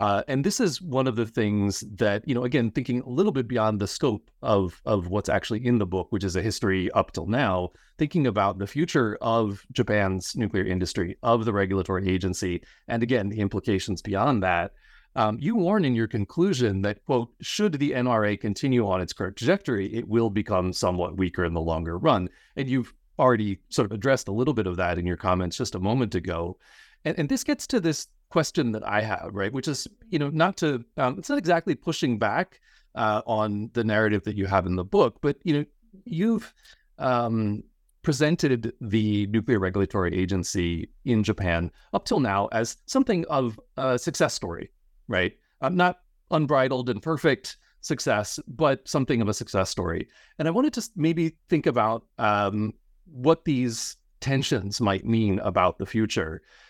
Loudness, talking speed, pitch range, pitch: -26 LUFS, 185 wpm, 95-135 Hz, 110 Hz